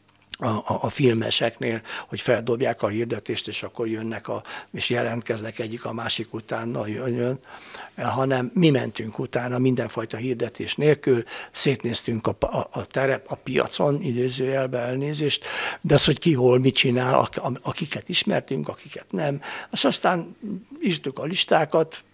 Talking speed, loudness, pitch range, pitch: 135 wpm, -23 LUFS, 115-145 Hz, 125 Hz